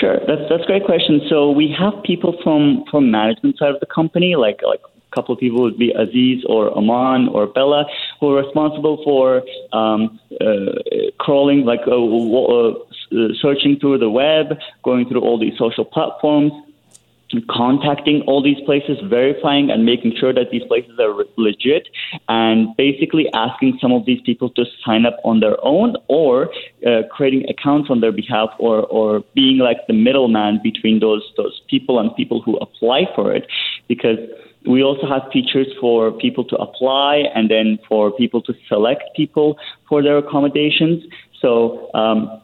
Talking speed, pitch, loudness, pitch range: 170 wpm, 140 Hz, -16 LUFS, 120-155 Hz